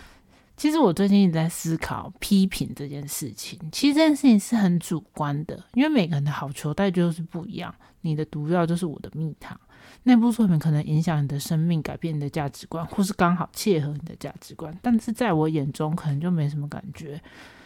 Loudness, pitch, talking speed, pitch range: -24 LUFS, 165 Hz, 325 characters per minute, 150-195 Hz